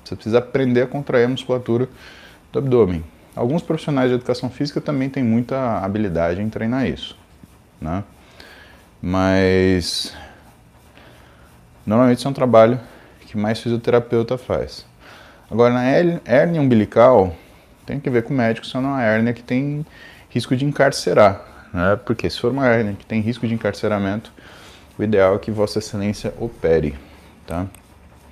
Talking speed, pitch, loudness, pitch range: 150 wpm, 115 Hz, -19 LUFS, 95-125 Hz